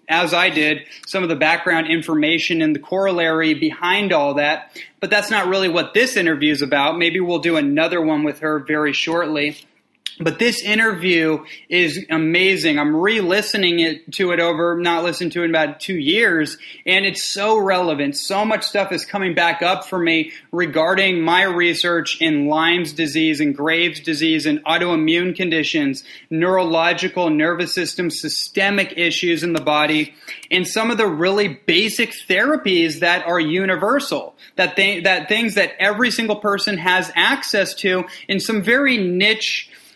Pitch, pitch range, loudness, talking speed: 175 Hz, 160-190 Hz, -17 LUFS, 165 wpm